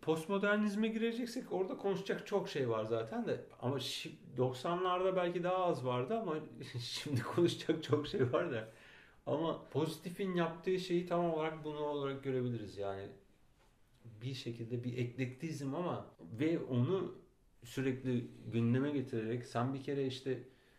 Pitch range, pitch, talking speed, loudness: 125-175 Hz, 140 Hz, 135 wpm, -38 LUFS